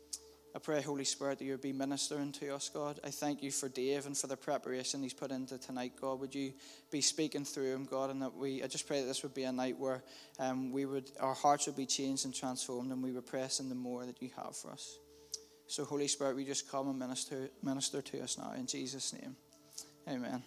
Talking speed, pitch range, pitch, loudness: 240 wpm, 130-145 Hz, 135 Hz, -39 LUFS